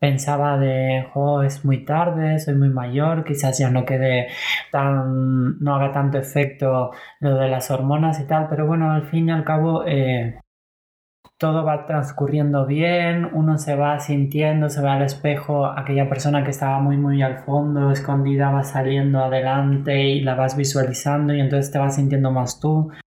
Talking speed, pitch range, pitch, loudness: 175 wpm, 135-150 Hz, 140 Hz, -20 LUFS